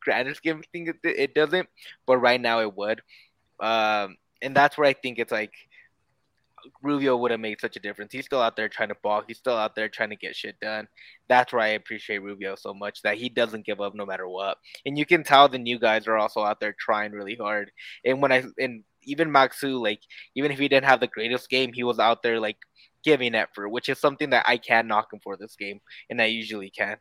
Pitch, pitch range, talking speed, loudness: 115 Hz, 105-135 Hz, 240 wpm, -24 LUFS